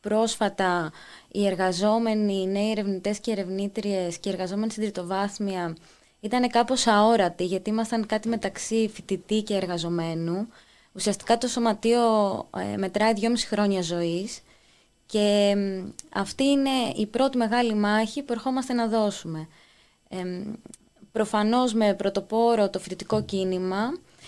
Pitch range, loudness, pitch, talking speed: 190-225 Hz, -25 LUFS, 210 Hz, 115 wpm